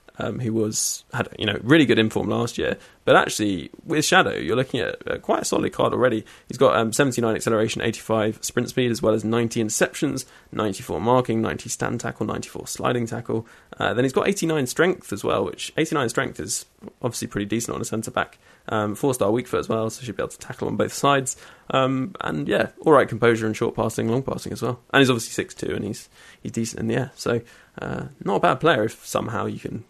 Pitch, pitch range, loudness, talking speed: 115 Hz, 110-130 Hz, -23 LUFS, 230 wpm